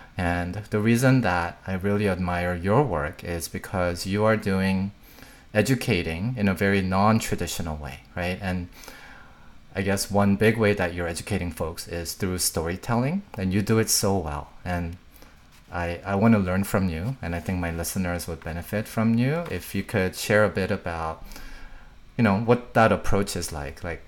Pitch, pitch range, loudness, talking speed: 95 Hz, 85-105 Hz, -25 LUFS, 180 wpm